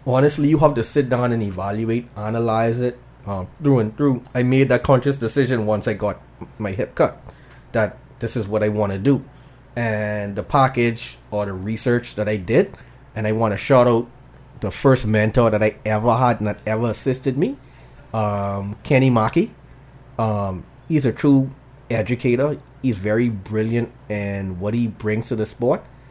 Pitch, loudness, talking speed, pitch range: 115 Hz, -20 LUFS, 180 wpm, 105-130 Hz